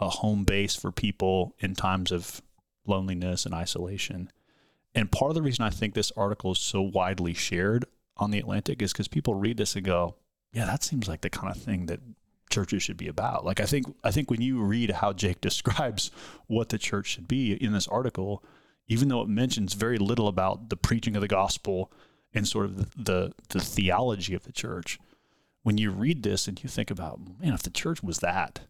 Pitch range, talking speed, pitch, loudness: 95-115 Hz, 215 wpm, 105 Hz, -29 LUFS